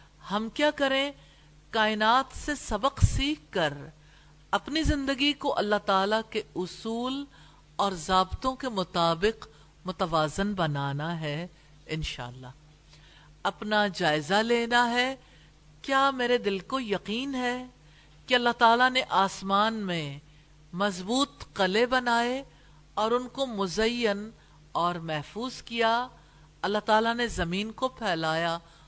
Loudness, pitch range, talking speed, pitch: -28 LUFS, 165-245 Hz, 115 wpm, 205 Hz